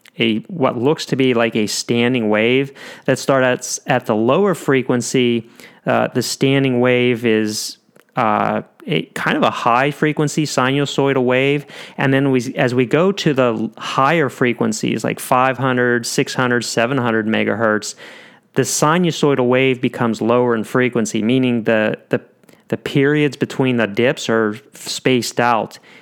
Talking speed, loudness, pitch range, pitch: 145 wpm, -17 LUFS, 115-135 Hz, 125 Hz